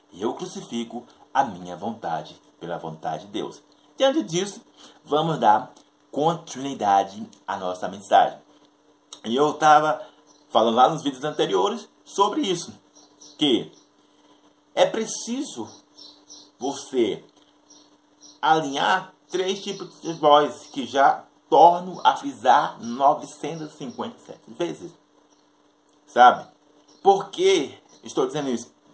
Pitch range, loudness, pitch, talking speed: 140-220 Hz, -23 LUFS, 165 Hz, 100 wpm